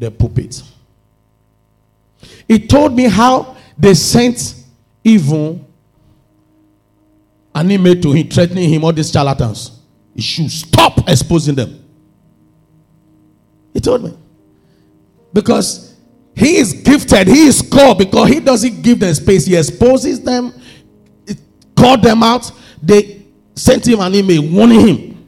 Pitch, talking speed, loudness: 155 Hz, 120 wpm, -10 LUFS